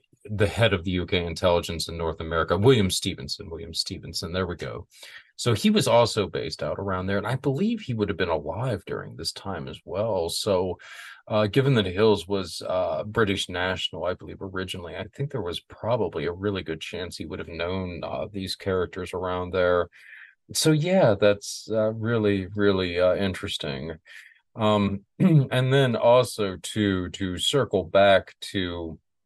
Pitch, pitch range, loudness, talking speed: 100 Hz, 90-110 Hz, -25 LUFS, 175 wpm